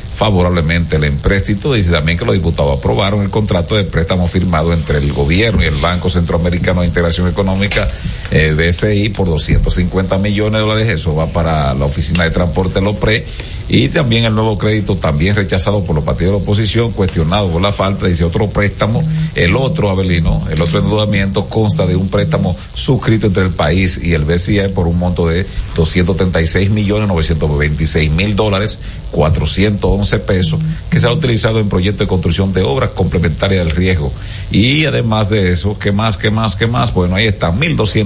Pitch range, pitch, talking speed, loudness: 85-105 Hz, 95 Hz, 180 wpm, -13 LUFS